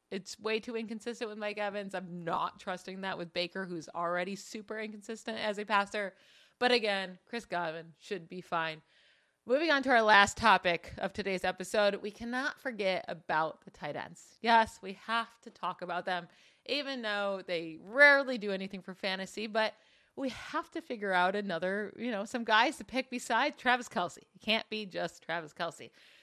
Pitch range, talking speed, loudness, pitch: 185-235 Hz, 185 wpm, -32 LUFS, 210 Hz